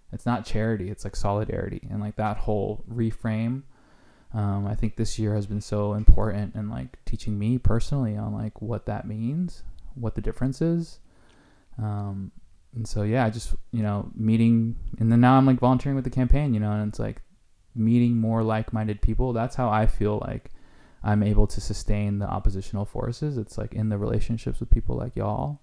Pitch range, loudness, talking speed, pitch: 105-120 Hz, -26 LUFS, 190 wpm, 110 Hz